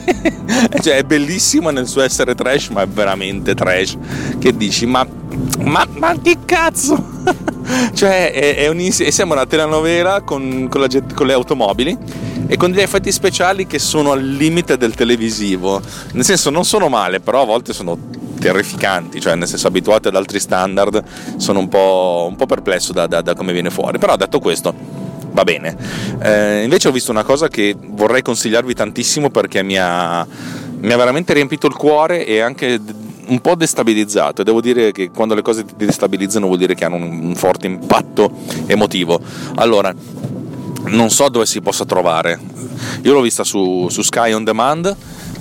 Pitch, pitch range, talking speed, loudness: 120 Hz, 100-150 Hz, 175 wpm, -14 LUFS